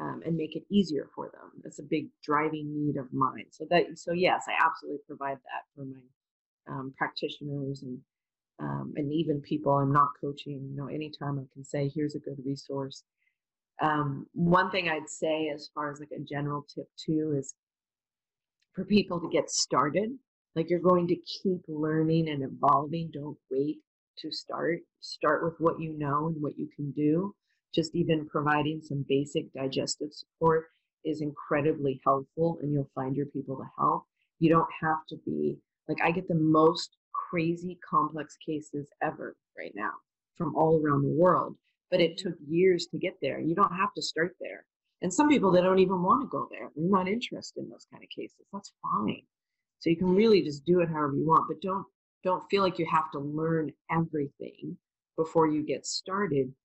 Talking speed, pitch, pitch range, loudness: 190 wpm, 155 Hz, 145-170 Hz, -29 LUFS